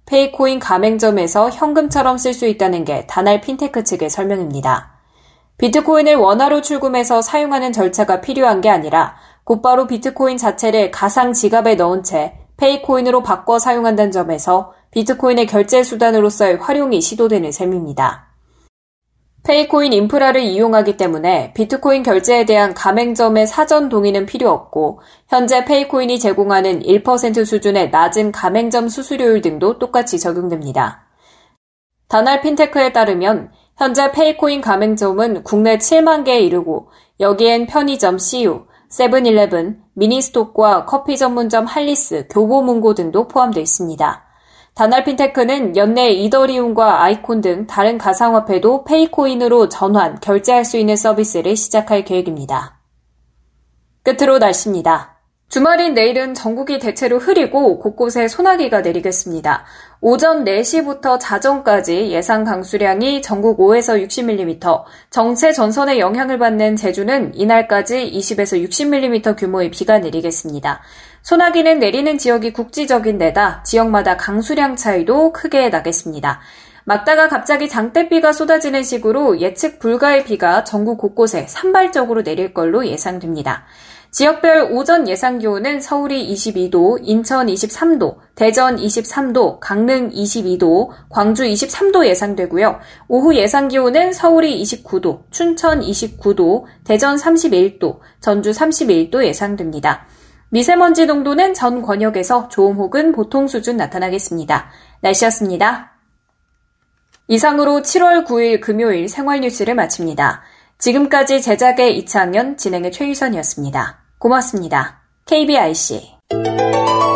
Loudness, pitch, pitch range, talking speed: -14 LUFS, 230 Hz, 200-275 Hz, 310 characters per minute